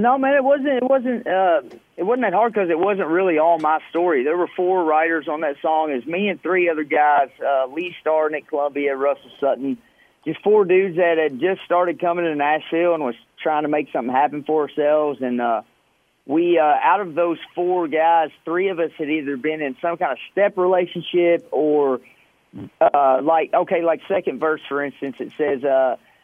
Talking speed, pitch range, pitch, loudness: 210 wpm, 150-180 Hz, 165 Hz, -20 LUFS